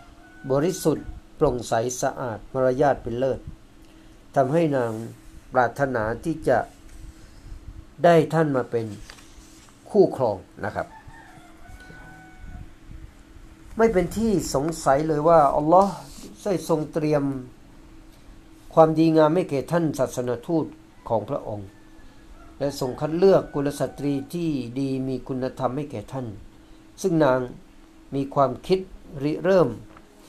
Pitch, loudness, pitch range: 140 Hz, -23 LUFS, 125-160 Hz